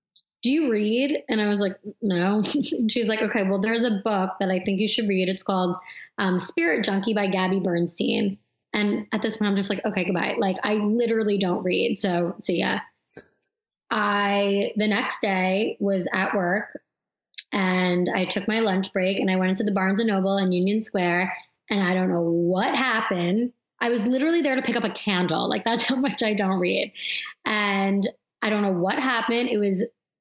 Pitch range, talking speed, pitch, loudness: 185-225 Hz, 205 wpm, 200 Hz, -24 LUFS